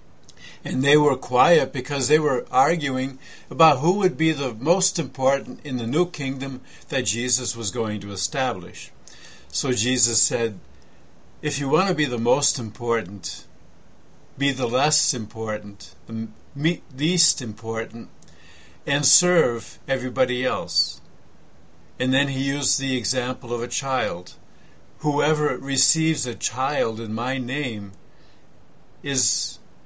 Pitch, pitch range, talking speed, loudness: 130 Hz, 115-145 Hz, 130 wpm, -22 LUFS